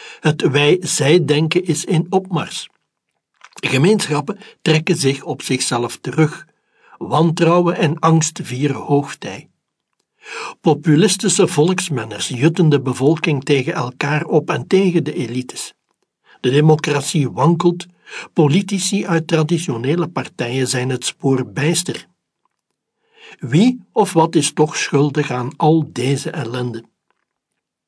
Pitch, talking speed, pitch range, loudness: 155 Hz, 105 wpm, 140-175 Hz, -17 LUFS